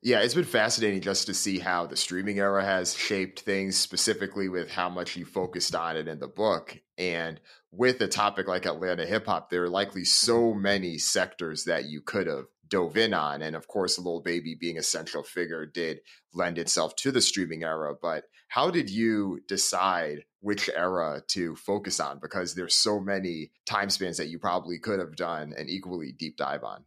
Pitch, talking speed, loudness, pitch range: 95 Hz, 200 wpm, -28 LUFS, 85-100 Hz